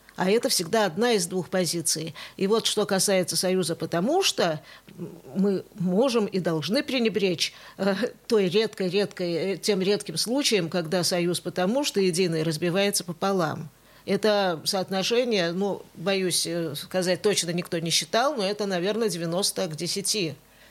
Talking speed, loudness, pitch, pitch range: 135 wpm, -25 LUFS, 185 Hz, 175-205 Hz